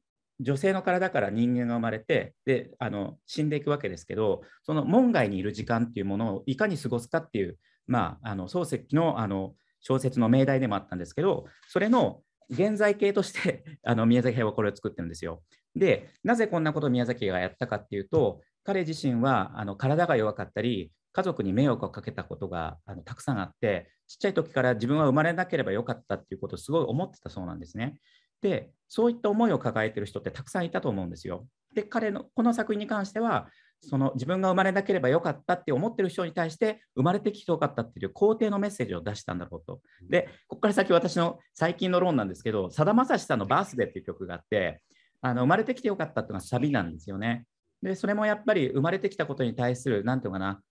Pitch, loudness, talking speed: 135 Hz, -28 LUFS, 470 characters per minute